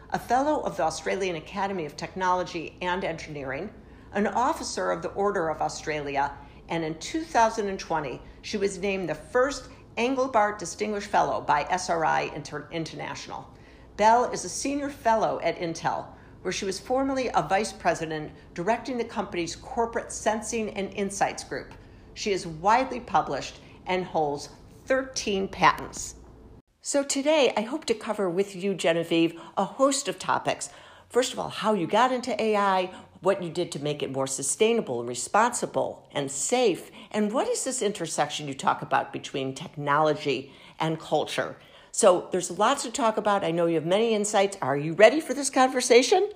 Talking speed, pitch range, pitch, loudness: 160 wpm, 160-225 Hz, 195 Hz, -26 LUFS